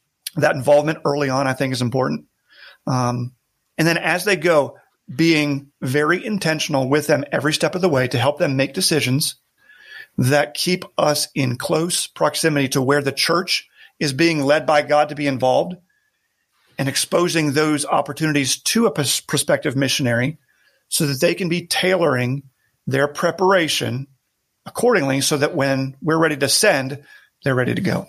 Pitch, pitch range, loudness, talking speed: 150 Hz, 135-165 Hz, -19 LUFS, 160 wpm